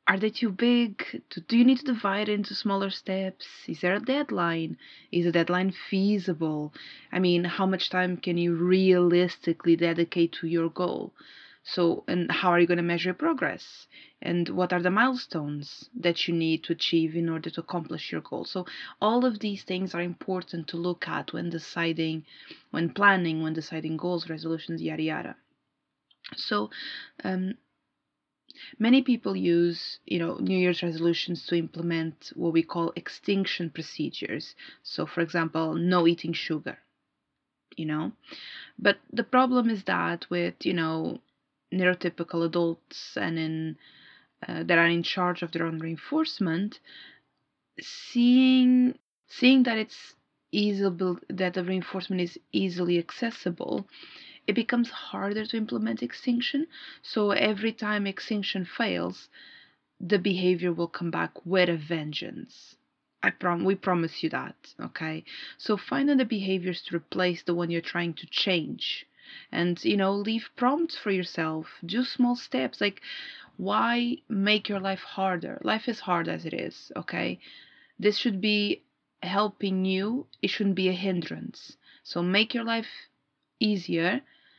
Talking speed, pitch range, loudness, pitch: 150 wpm, 170-215 Hz, -27 LUFS, 185 Hz